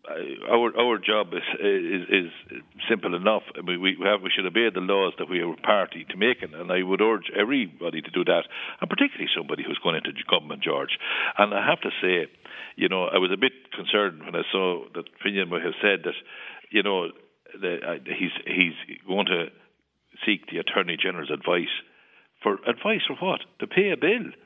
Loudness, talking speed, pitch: -25 LUFS, 200 wpm, 275 Hz